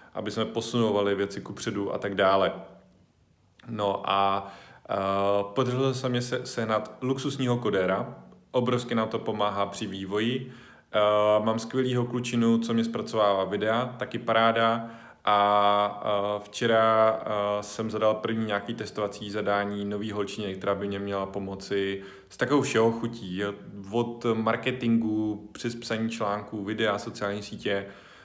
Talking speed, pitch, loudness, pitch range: 135 wpm, 110 Hz, -27 LUFS, 100-115 Hz